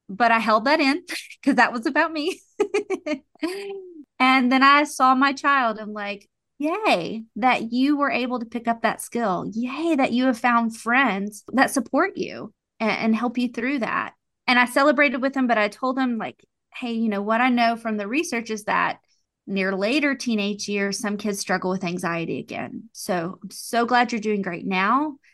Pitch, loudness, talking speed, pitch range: 245 Hz, -22 LUFS, 195 wpm, 215-280 Hz